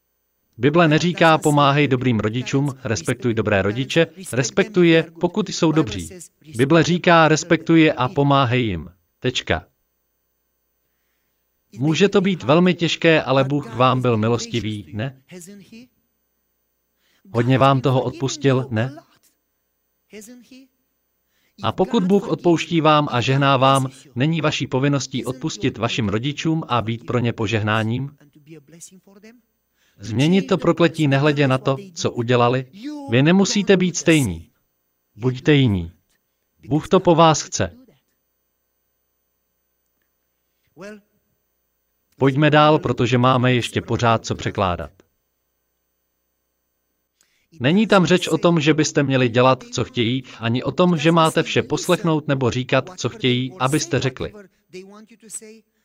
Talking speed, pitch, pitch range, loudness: 115 wpm, 130 Hz, 105-165 Hz, -18 LUFS